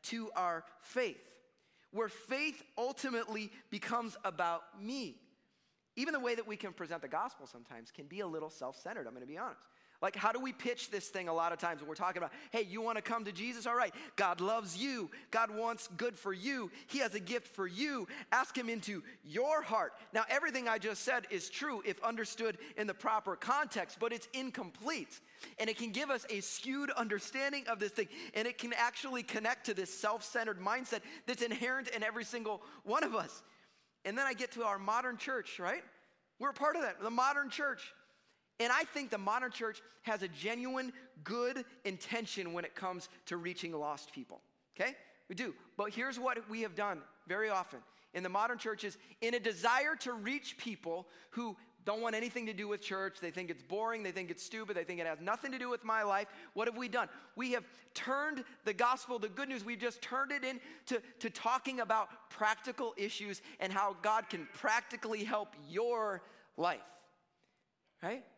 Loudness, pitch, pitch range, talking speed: -38 LUFS, 225 Hz, 205-255 Hz, 200 wpm